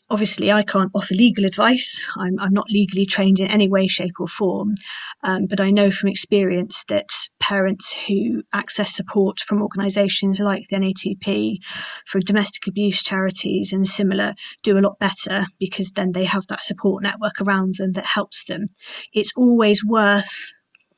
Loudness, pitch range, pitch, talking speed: -19 LUFS, 190-205 Hz, 200 Hz, 165 wpm